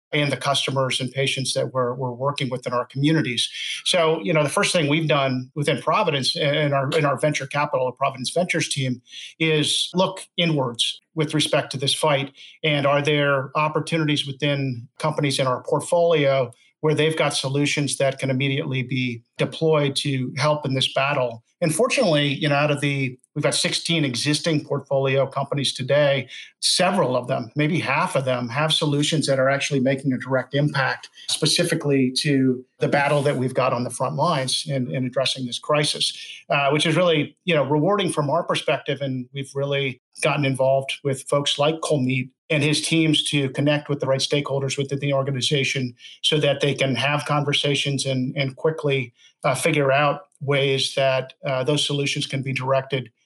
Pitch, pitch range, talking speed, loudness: 140 Hz, 135-150 Hz, 180 wpm, -22 LUFS